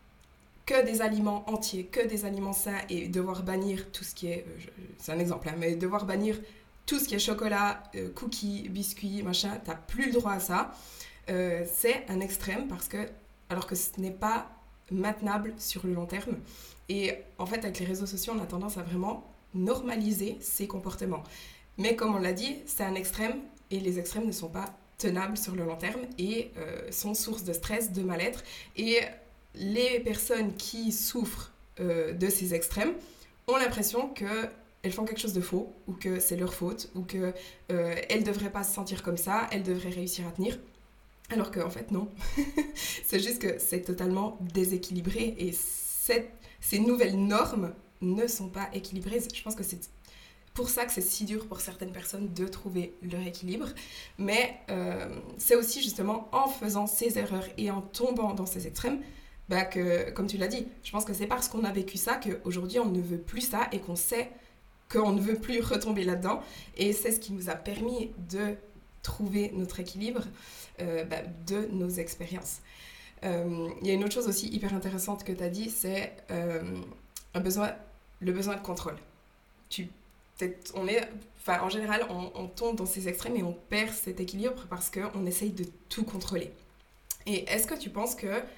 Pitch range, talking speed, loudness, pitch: 185-220 Hz, 190 wpm, -32 LUFS, 200 Hz